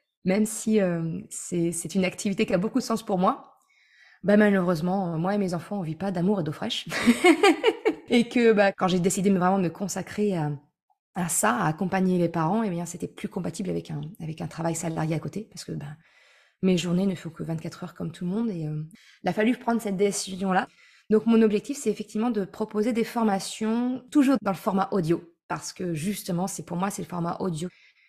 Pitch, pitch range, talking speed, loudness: 195 Hz, 175-220 Hz, 220 wpm, -26 LUFS